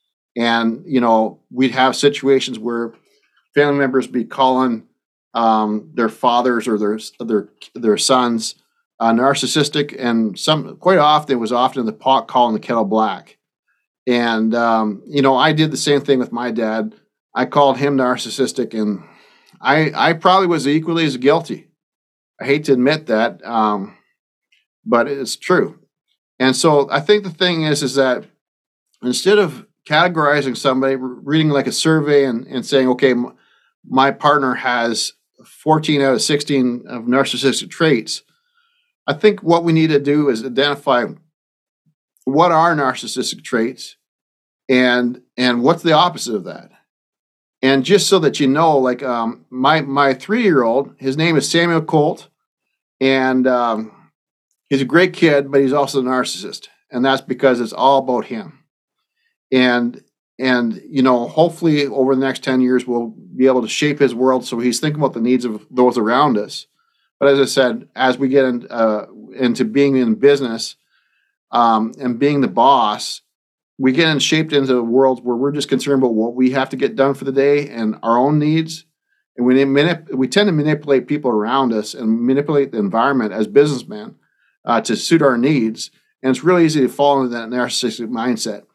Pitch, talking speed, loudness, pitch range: 130 Hz, 170 wpm, -16 LUFS, 120-145 Hz